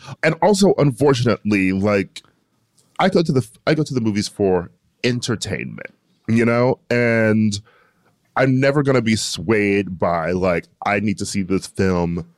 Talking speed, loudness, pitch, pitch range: 155 wpm, -19 LUFS, 110 Hz, 100-130 Hz